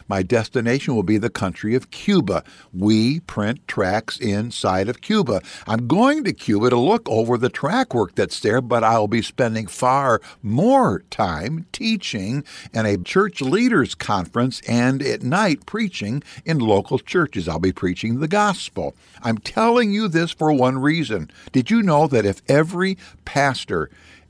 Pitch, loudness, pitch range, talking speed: 125 Hz, -20 LUFS, 110-165 Hz, 160 wpm